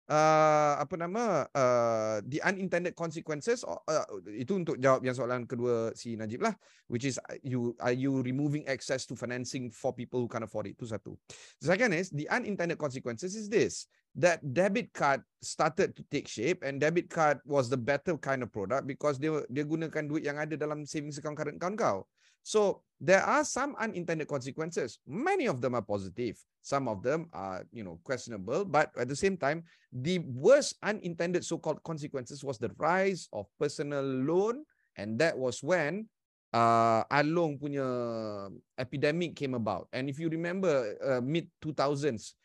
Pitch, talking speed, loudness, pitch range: 150 Hz, 180 wpm, -32 LUFS, 130-175 Hz